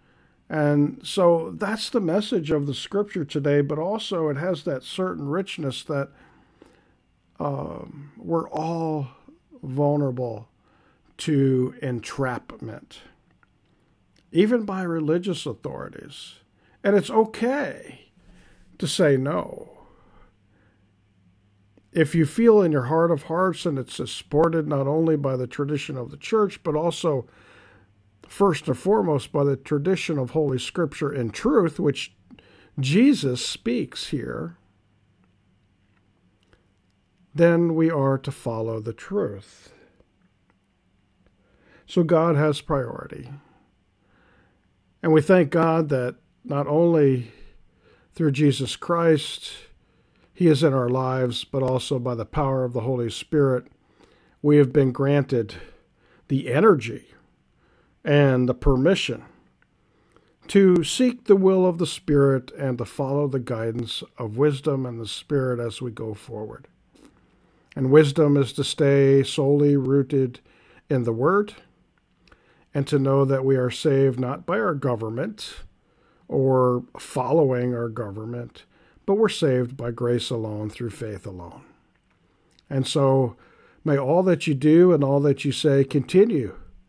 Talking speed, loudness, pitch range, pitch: 125 wpm, -23 LUFS, 120-160 Hz, 140 Hz